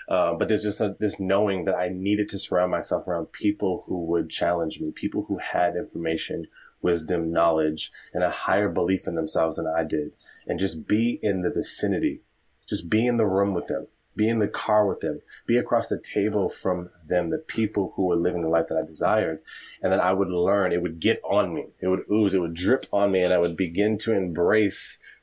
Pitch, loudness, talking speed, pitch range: 95 Hz, -25 LUFS, 220 wpm, 85-105 Hz